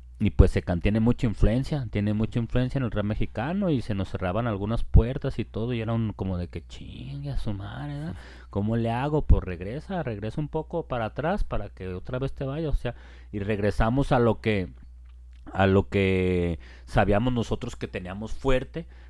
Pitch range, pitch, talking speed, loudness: 95-125 Hz, 110 Hz, 195 wpm, -27 LUFS